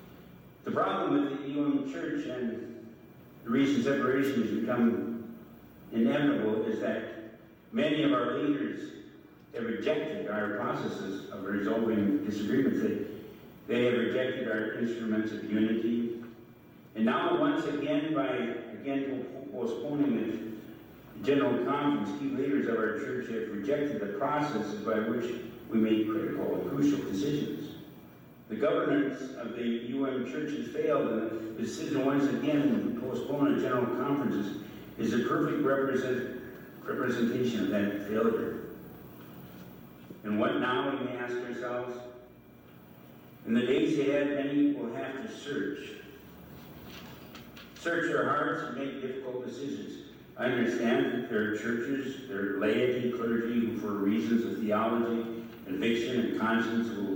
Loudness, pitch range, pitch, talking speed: -31 LUFS, 110-135 Hz, 115 Hz, 135 wpm